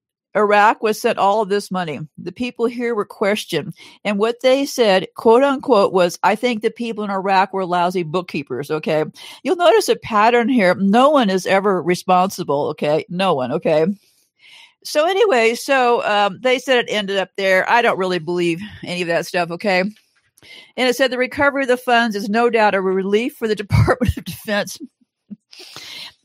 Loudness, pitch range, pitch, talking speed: -17 LUFS, 185-245 Hz, 210 Hz, 185 wpm